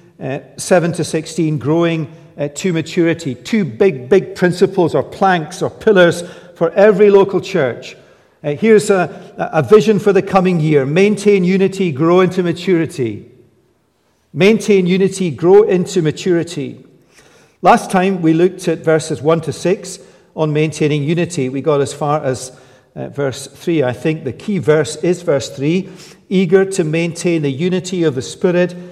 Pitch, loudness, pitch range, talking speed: 175 Hz, -15 LUFS, 155-190 Hz, 155 wpm